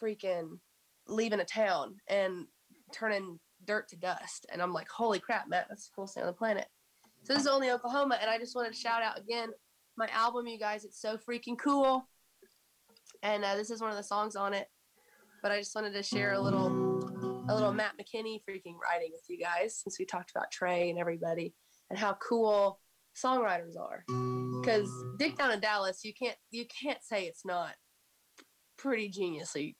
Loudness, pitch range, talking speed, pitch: -34 LUFS, 180-225 Hz, 195 wpm, 210 Hz